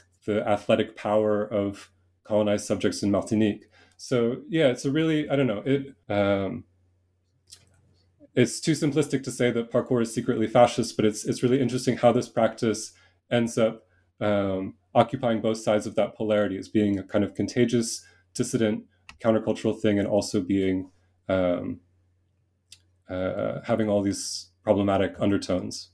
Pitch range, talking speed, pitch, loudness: 95-120 Hz, 145 wpm, 105 Hz, -25 LUFS